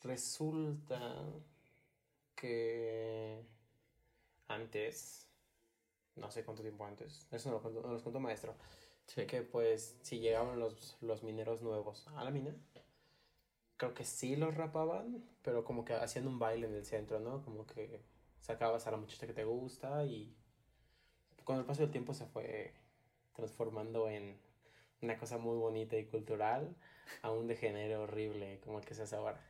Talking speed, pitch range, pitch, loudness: 160 wpm, 110-130 Hz, 115 Hz, -42 LUFS